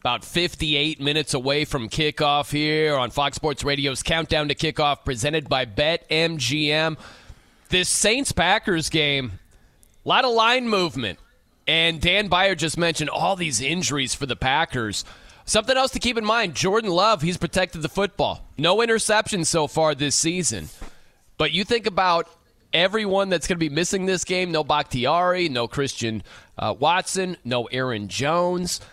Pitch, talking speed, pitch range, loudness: 160 Hz, 160 wpm, 145-180 Hz, -21 LUFS